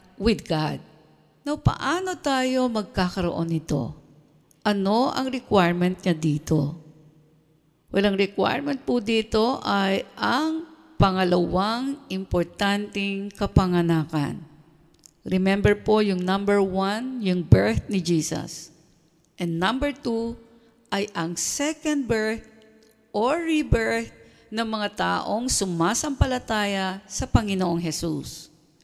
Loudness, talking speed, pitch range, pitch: -24 LUFS, 100 wpm, 165-225 Hz, 195 Hz